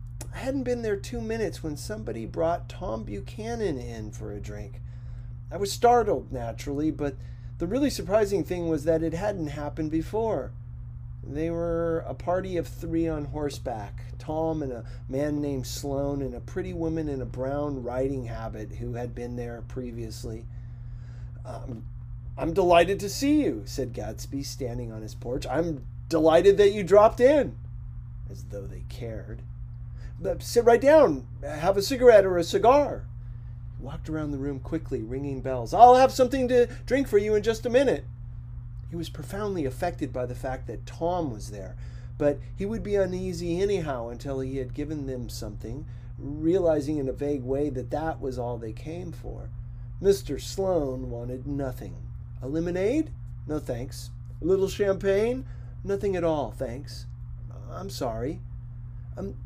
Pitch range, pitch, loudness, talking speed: 120-165 Hz, 130 Hz, -26 LUFS, 160 wpm